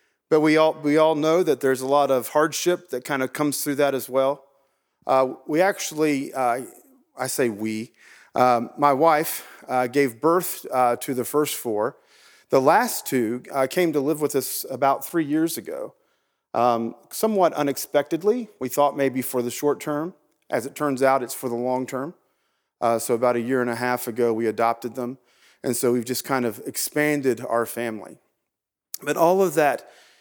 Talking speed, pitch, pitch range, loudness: 190 wpm, 135 Hz, 125-155 Hz, -23 LUFS